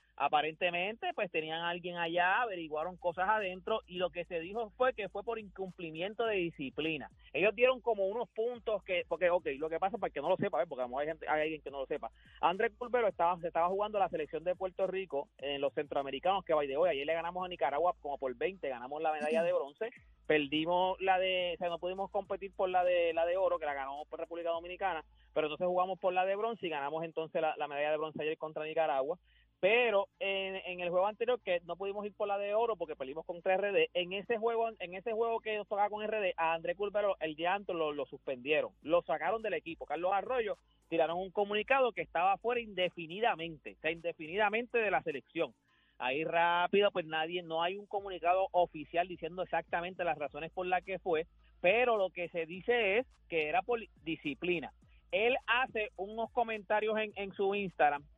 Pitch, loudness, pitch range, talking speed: 180 Hz, -34 LUFS, 165-205 Hz, 220 wpm